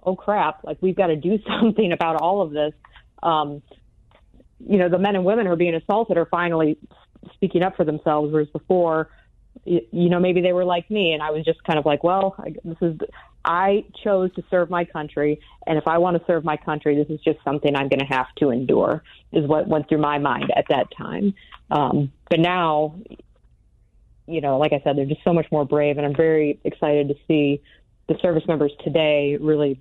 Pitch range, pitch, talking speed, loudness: 150-180 Hz, 160 Hz, 215 wpm, -21 LUFS